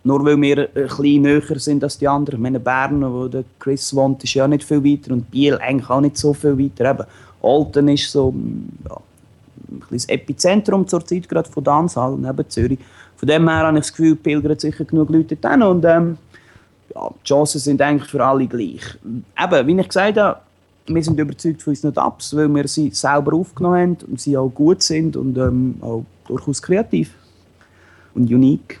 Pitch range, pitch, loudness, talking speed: 130-155 Hz, 145 Hz, -17 LUFS, 200 wpm